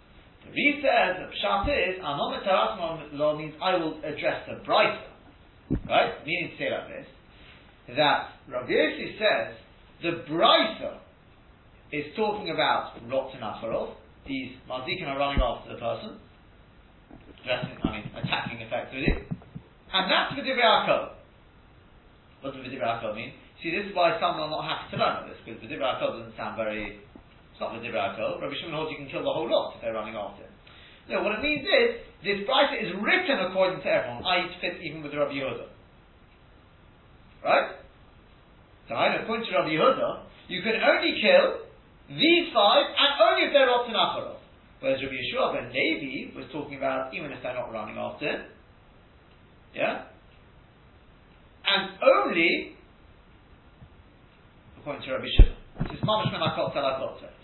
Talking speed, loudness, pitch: 150 wpm, -26 LUFS, 175 Hz